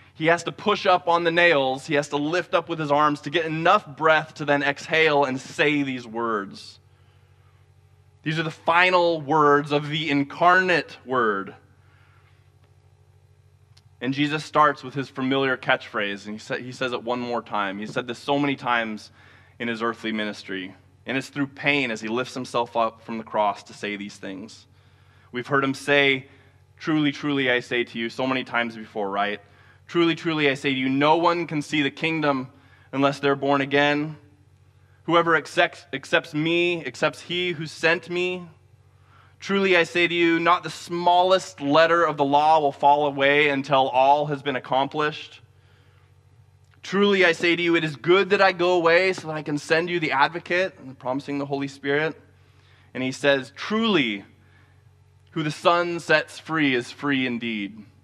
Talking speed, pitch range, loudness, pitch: 180 wpm, 110-160 Hz, -22 LUFS, 140 Hz